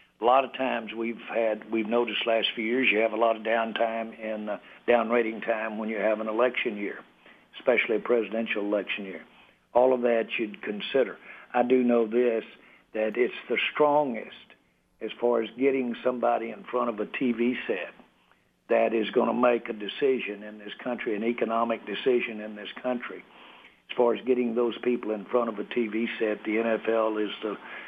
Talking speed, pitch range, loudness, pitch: 190 wpm, 110-120 Hz, -27 LUFS, 115 Hz